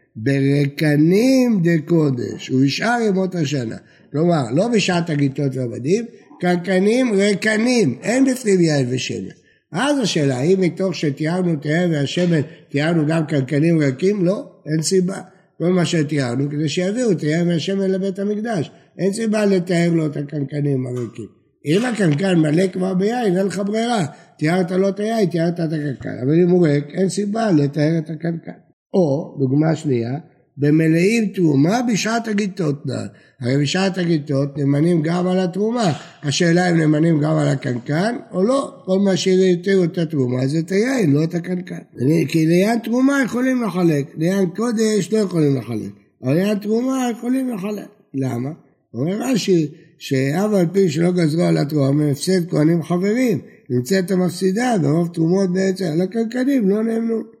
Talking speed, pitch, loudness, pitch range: 155 wpm, 175 Hz, -19 LUFS, 150-195 Hz